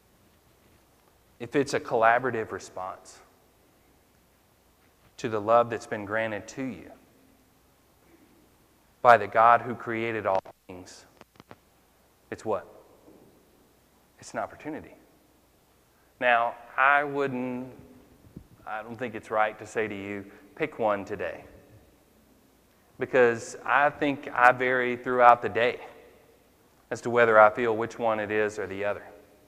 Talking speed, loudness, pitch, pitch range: 120 wpm, -25 LUFS, 115 Hz, 105-125 Hz